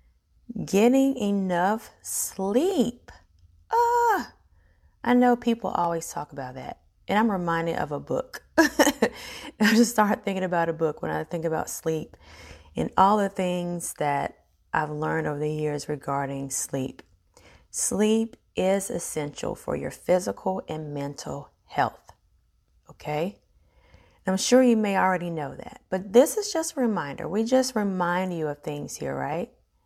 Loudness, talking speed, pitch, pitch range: -26 LUFS, 145 wpm, 185 Hz, 150-225 Hz